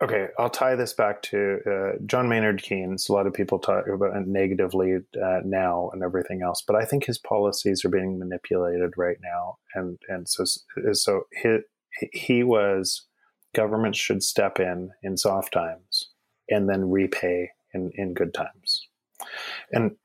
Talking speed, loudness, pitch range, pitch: 160 wpm, -25 LUFS, 90-105 Hz, 95 Hz